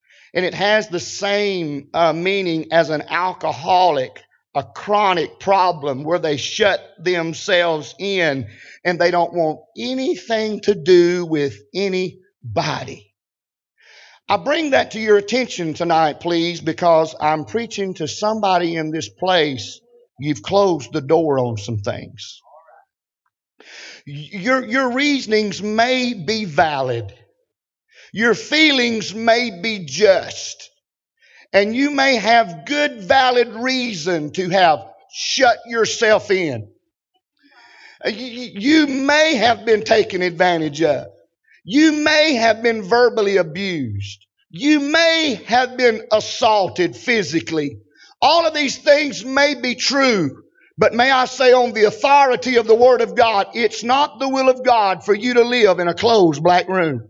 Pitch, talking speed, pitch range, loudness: 200 Hz, 130 wpm, 165-245 Hz, -17 LUFS